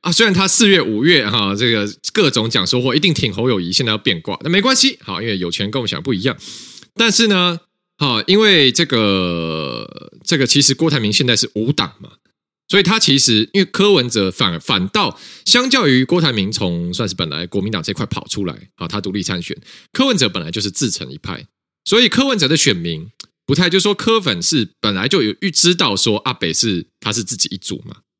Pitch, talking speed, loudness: 145 Hz, 320 characters per minute, -15 LUFS